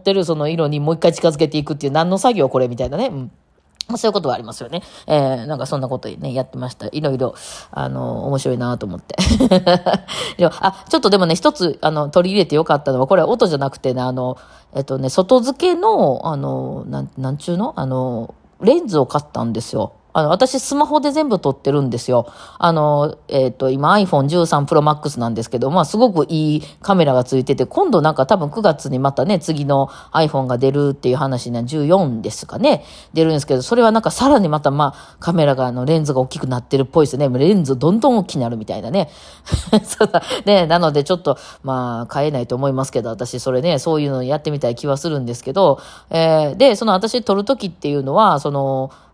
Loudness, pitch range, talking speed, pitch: -17 LUFS, 130-180 Hz, 440 characters per minute, 150 Hz